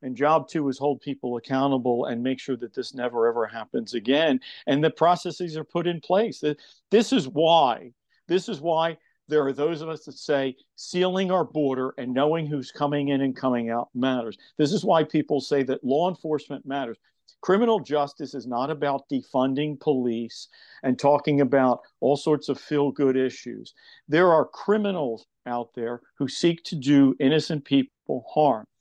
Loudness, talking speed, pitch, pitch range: -24 LUFS, 175 wpm, 145 Hz, 130-165 Hz